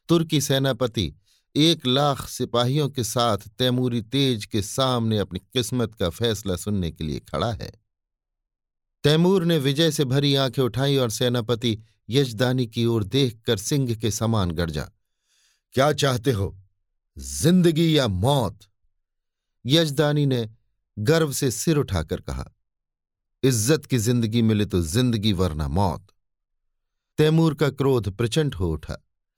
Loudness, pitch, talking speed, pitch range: -23 LUFS, 120 Hz, 130 wpm, 100-140 Hz